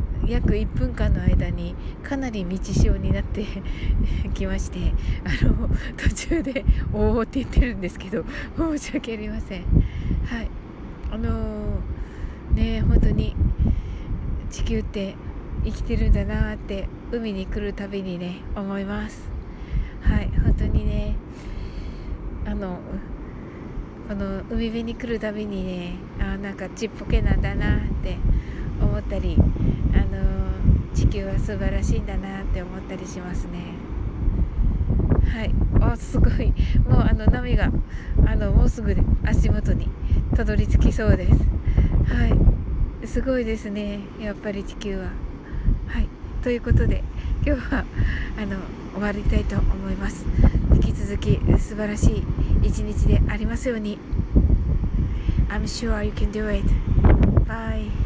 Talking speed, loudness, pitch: 260 characters per minute, -24 LUFS, 110 Hz